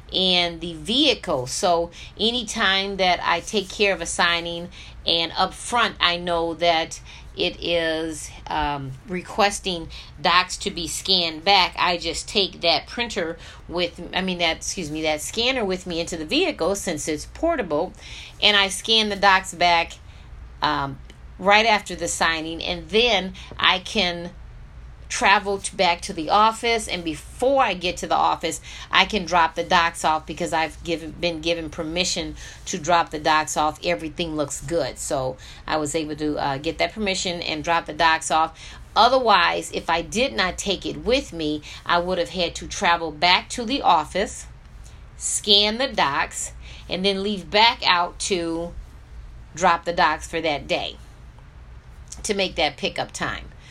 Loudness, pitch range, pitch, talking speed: -21 LUFS, 160-195 Hz, 170 Hz, 165 wpm